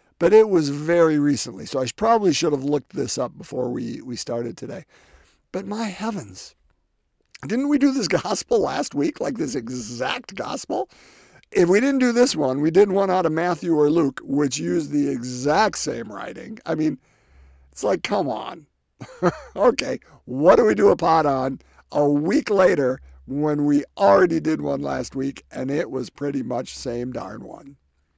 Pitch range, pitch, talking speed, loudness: 130-190 Hz, 145 Hz, 180 wpm, -21 LUFS